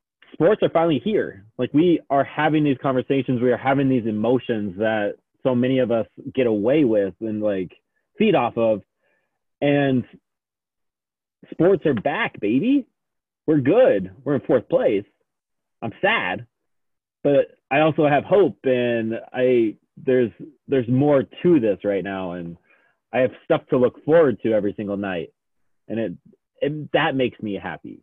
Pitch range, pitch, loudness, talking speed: 105-145 Hz, 125 Hz, -21 LUFS, 155 wpm